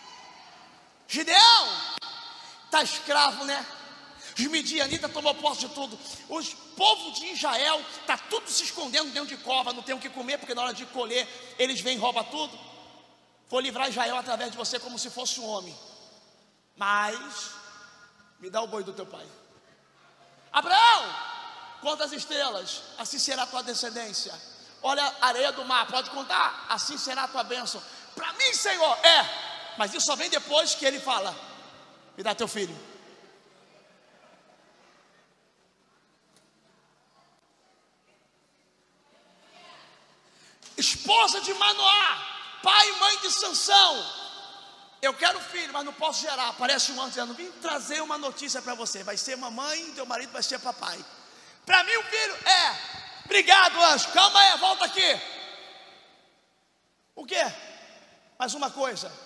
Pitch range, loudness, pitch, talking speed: 245-335 Hz, -24 LUFS, 285 Hz, 145 wpm